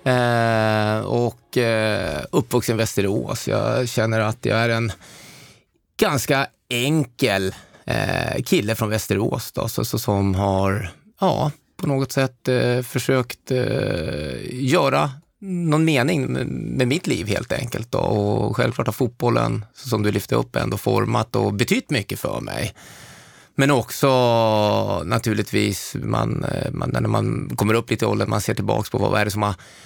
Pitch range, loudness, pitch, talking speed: 105-130 Hz, -21 LUFS, 115 Hz, 155 wpm